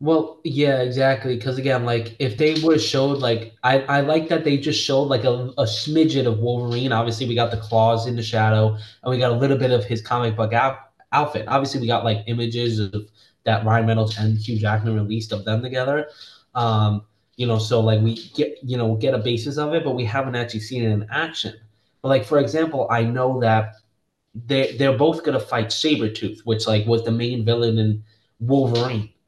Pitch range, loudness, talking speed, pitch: 110-135 Hz, -21 LUFS, 215 wpm, 120 Hz